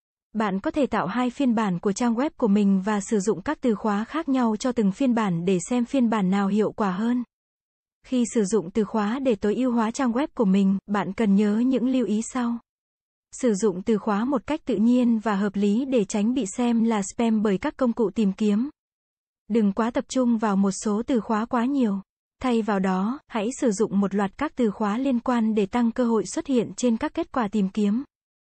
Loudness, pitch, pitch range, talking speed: -24 LUFS, 225 Hz, 210-250 Hz, 235 wpm